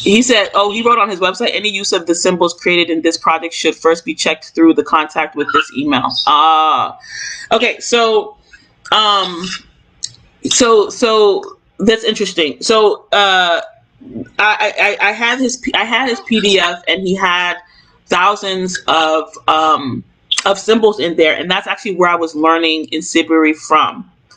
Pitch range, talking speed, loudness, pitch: 165-225 Hz, 165 wpm, -13 LUFS, 190 Hz